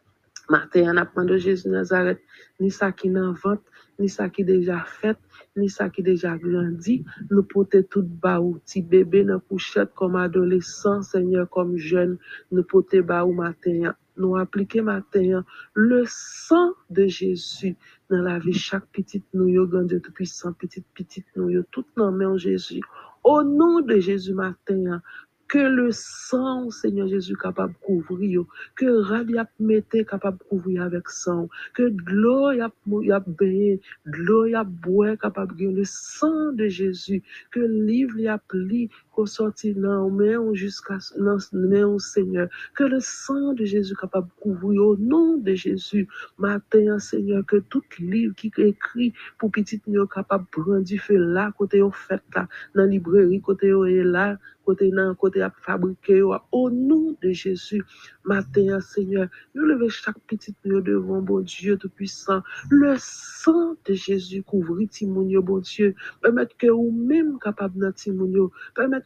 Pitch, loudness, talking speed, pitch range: 195 Hz, -22 LUFS, 150 wpm, 185-215 Hz